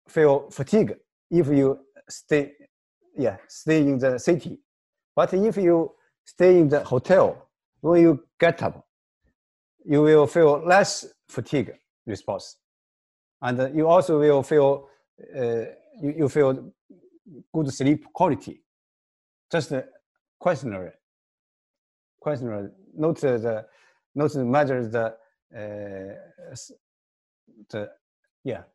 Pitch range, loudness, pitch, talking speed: 125-170 Hz, -22 LUFS, 145 Hz, 110 wpm